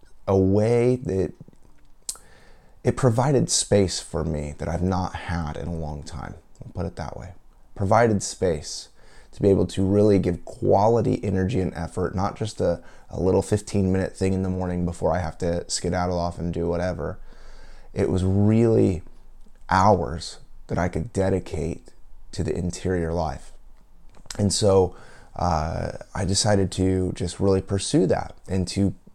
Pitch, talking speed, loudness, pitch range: 95 Hz, 160 wpm, -24 LUFS, 85-100 Hz